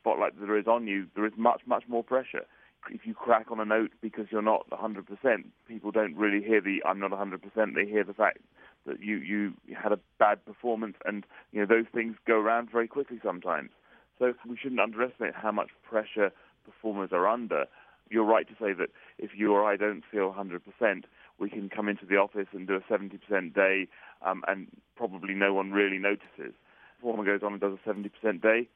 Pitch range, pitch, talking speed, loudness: 100-115 Hz, 105 Hz, 205 wpm, -30 LUFS